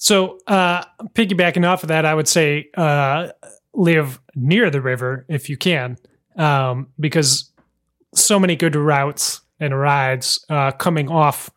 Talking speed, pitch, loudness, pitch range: 145 wpm, 155 Hz, -17 LUFS, 140-175 Hz